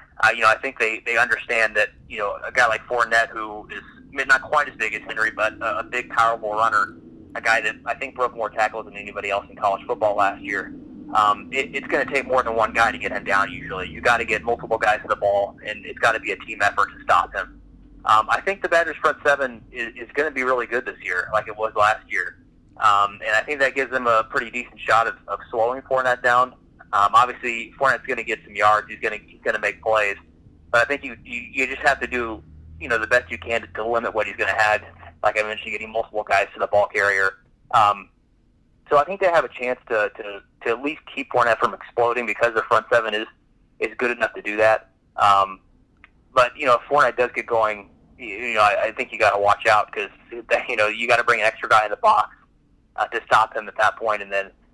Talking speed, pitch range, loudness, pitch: 260 wpm, 105-125 Hz, -21 LUFS, 115 Hz